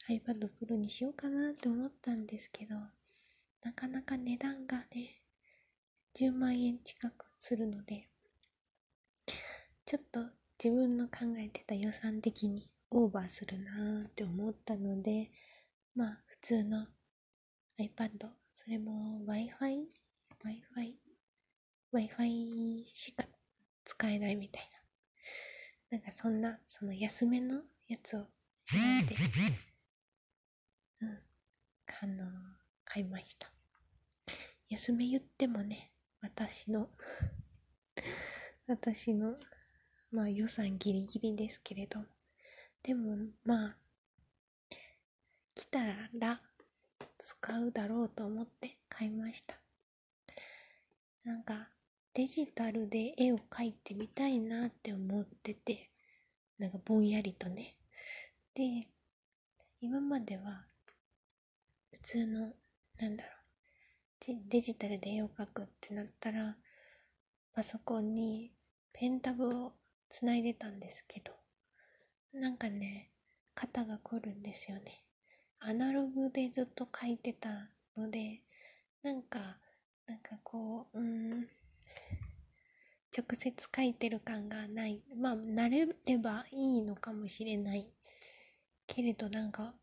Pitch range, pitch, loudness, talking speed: 215-245 Hz, 225 Hz, -39 LUFS, 220 characters per minute